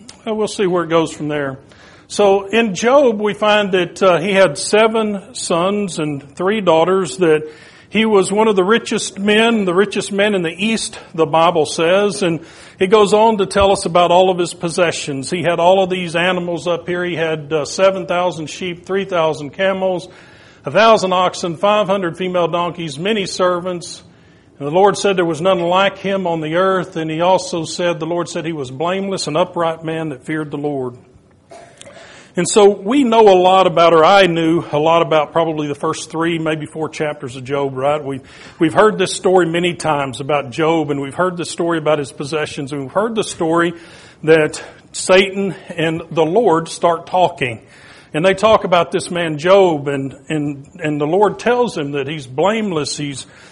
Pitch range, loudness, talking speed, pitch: 155-195 Hz, -16 LUFS, 190 wpm, 175 Hz